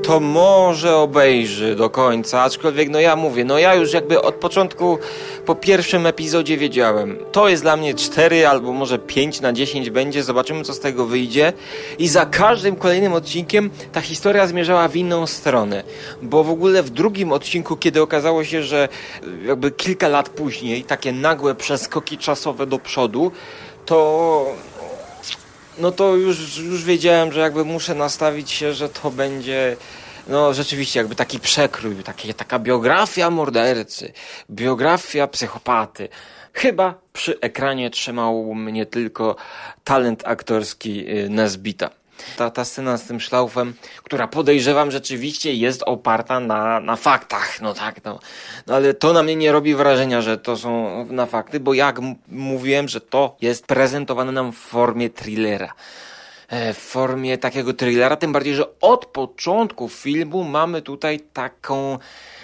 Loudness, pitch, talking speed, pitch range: -18 LUFS, 140 Hz, 150 wpm, 125-160 Hz